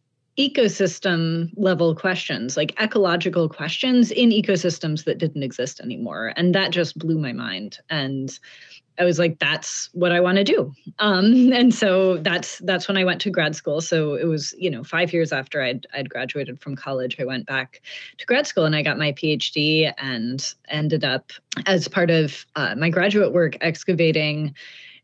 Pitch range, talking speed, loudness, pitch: 150-185 Hz, 175 wpm, -21 LUFS, 165 Hz